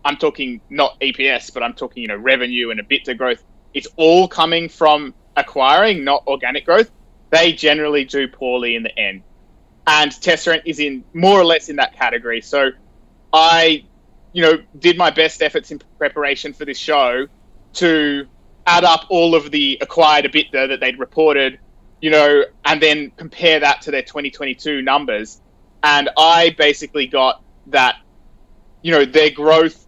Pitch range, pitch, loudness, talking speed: 135-160 Hz, 150 Hz, -15 LUFS, 170 wpm